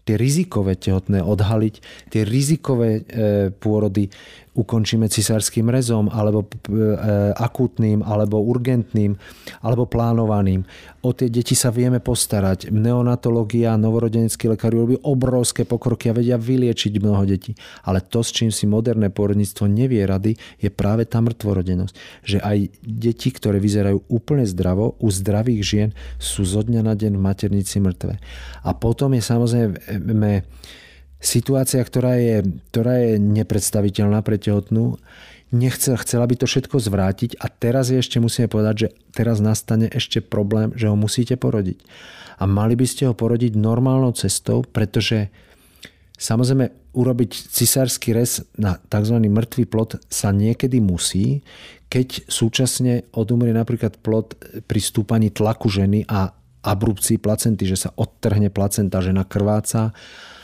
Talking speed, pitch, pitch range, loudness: 135 wpm, 110 Hz, 105-120 Hz, -20 LUFS